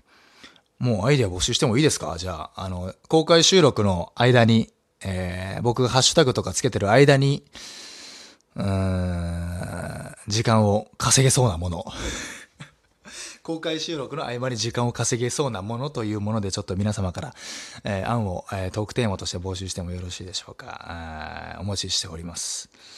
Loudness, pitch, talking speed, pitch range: -23 LUFS, 105 Hz, 335 characters per minute, 95-125 Hz